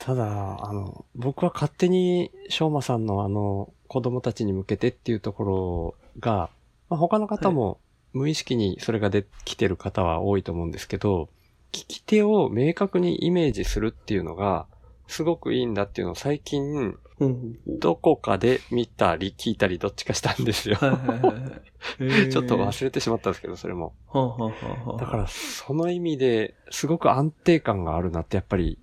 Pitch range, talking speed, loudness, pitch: 100-145 Hz, 330 characters per minute, -25 LUFS, 115 Hz